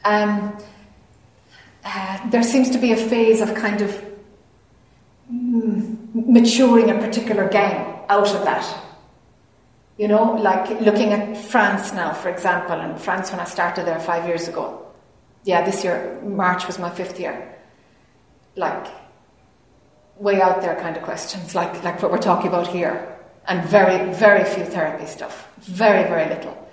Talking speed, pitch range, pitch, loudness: 155 wpm, 180-215 Hz, 200 Hz, -19 LUFS